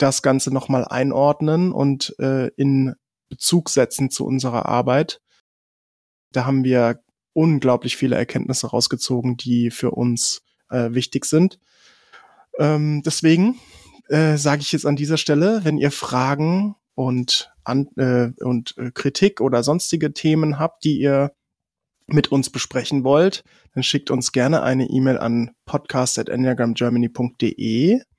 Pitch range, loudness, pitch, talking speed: 125-150 Hz, -20 LUFS, 135 Hz, 130 wpm